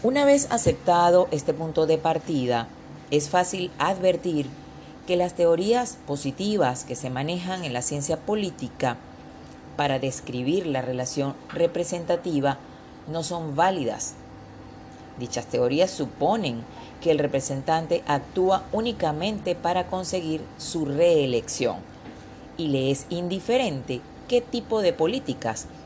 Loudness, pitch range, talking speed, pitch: -25 LUFS, 135-180 Hz, 115 wpm, 160 Hz